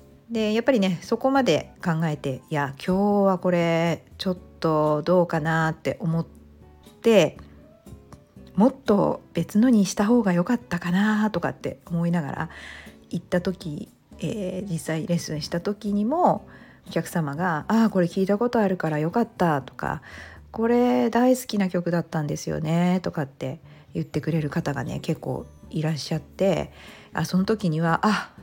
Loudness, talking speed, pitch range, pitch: -24 LUFS, 300 characters per minute, 160-205 Hz, 175 Hz